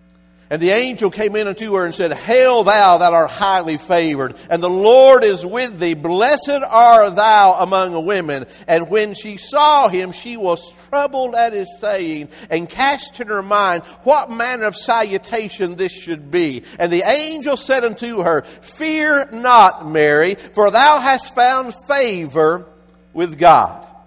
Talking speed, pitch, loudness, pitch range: 160 wpm, 205 Hz, -15 LUFS, 170-245 Hz